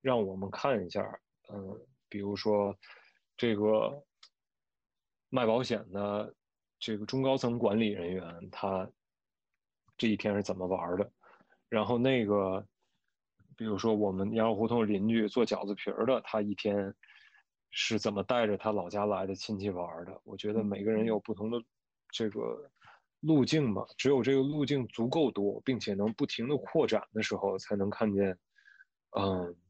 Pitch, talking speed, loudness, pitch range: 105 Hz, 225 characters per minute, -32 LUFS, 100-115 Hz